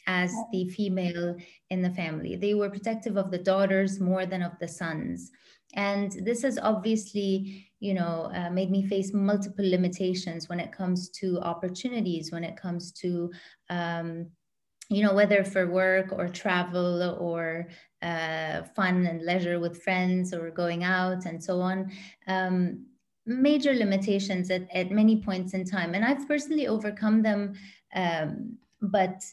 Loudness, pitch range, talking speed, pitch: -28 LUFS, 175-200 Hz, 155 wpm, 185 Hz